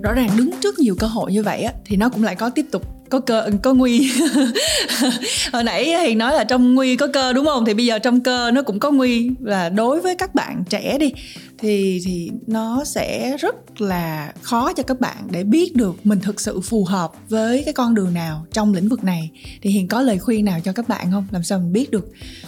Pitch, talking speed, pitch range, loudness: 225 Hz, 240 wpm, 200-260 Hz, -19 LUFS